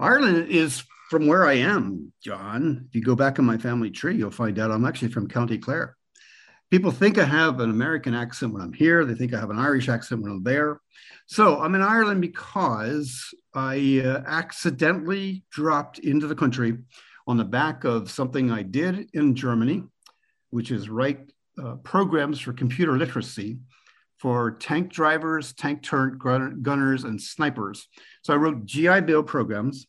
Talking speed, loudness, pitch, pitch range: 175 wpm, -23 LUFS, 135 Hz, 120-160 Hz